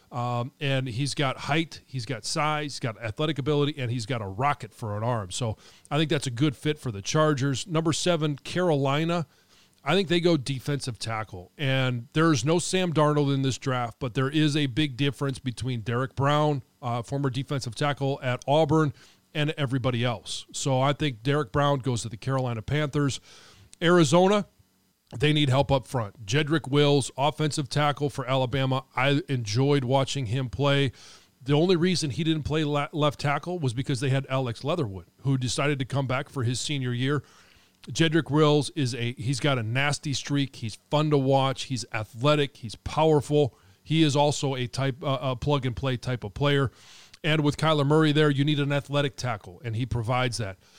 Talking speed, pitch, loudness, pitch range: 190 wpm, 140 Hz, -26 LUFS, 125-150 Hz